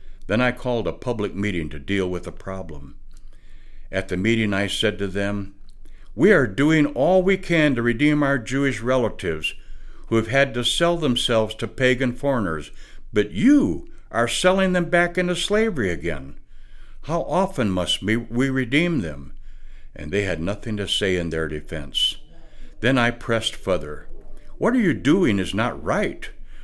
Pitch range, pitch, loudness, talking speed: 95-140 Hz, 115 Hz, -22 LUFS, 165 wpm